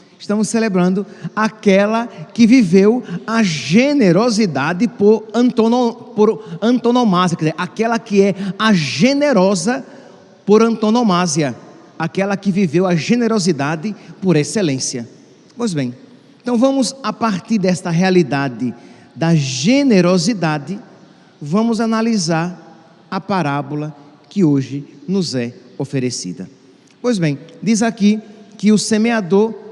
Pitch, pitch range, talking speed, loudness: 195 Hz, 165-225 Hz, 105 wpm, -16 LUFS